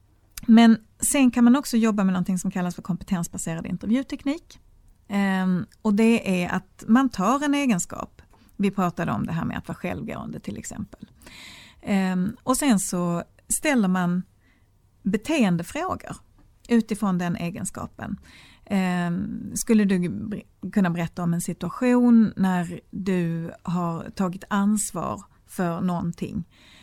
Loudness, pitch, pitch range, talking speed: -24 LUFS, 190 Hz, 180-225 Hz, 130 wpm